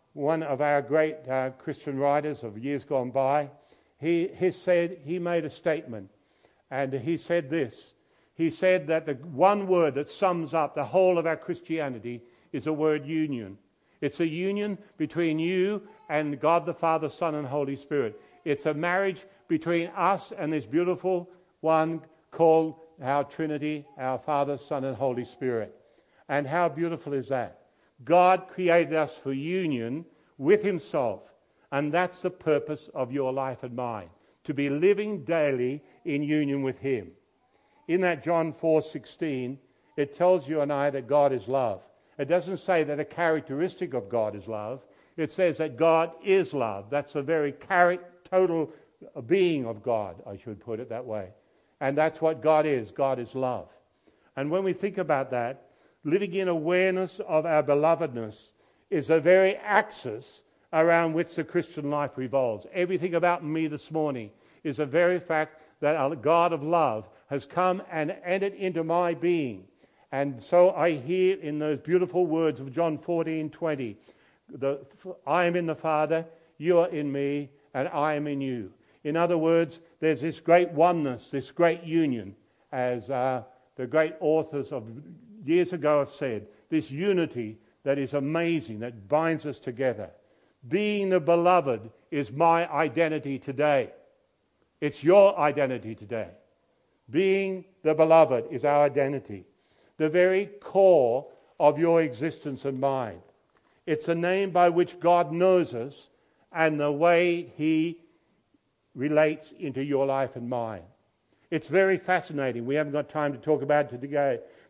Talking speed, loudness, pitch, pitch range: 160 wpm, -27 LUFS, 155 Hz, 140-175 Hz